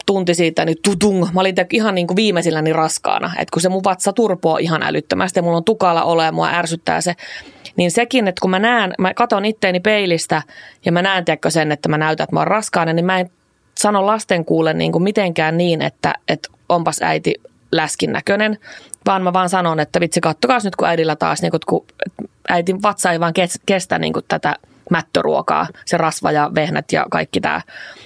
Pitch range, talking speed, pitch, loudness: 165-200 Hz, 195 wpm, 180 Hz, -17 LUFS